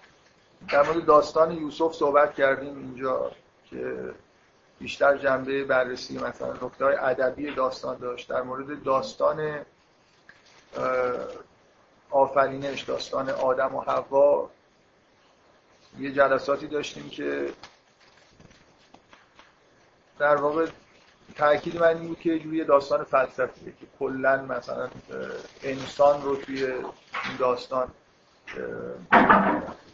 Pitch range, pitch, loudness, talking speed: 130-150 Hz, 140 Hz, -25 LUFS, 90 wpm